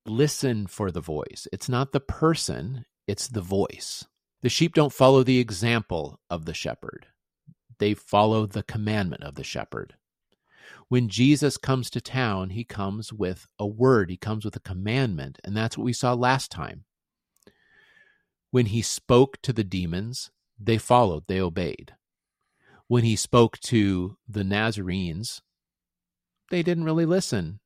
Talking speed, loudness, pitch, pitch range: 150 wpm, -25 LUFS, 115 Hz, 100-130 Hz